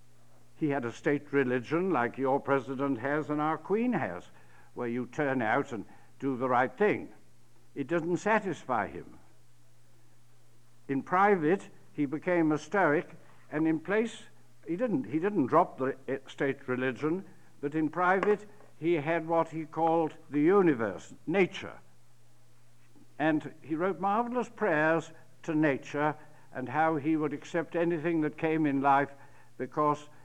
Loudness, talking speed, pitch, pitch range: -30 LUFS, 145 wpm, 150 Hz, 125-165 Hz